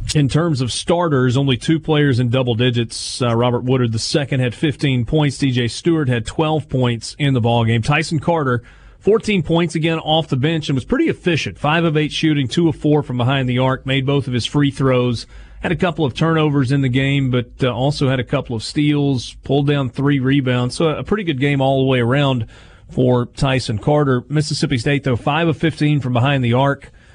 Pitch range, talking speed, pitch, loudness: 125-150 Hz, 215 wpm, 140 Hz, -17 LUFS